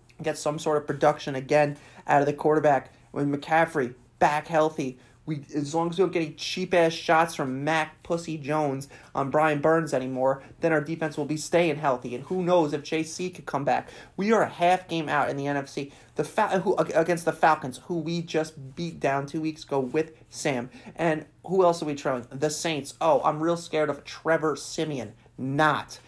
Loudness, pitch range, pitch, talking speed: -26 LUFS, 140-165 Hz, 155 Hz, 205 wpm